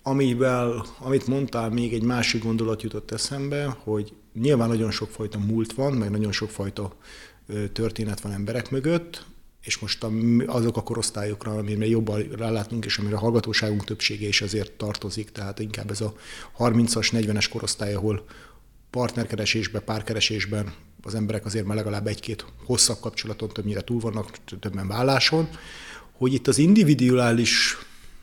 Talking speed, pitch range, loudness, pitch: 140 wpm, 105-120 Hz, -25 LUFS, 110 Hz